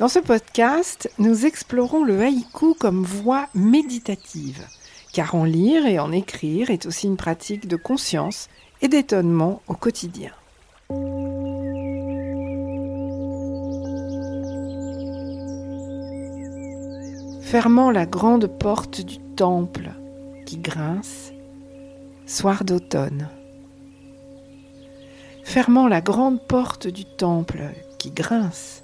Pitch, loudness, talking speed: 155 Hz, -22 LUFS, 90 wpm